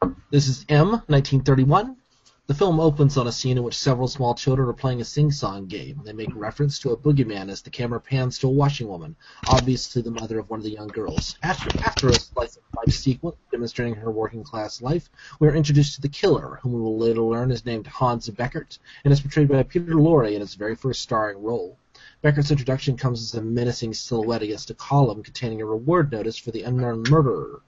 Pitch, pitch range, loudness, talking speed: 130 Hz, 115-145 Hz, -23 LUFS, 215 wpm